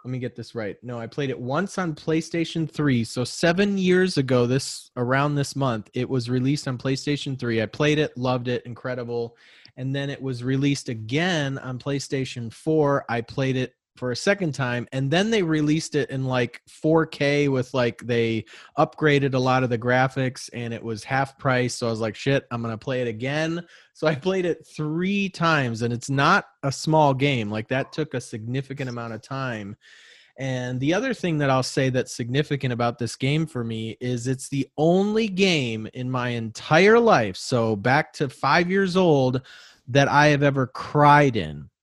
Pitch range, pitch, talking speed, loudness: 125-150 Hz, 135 Hz, 195 wpm, -23 LUFS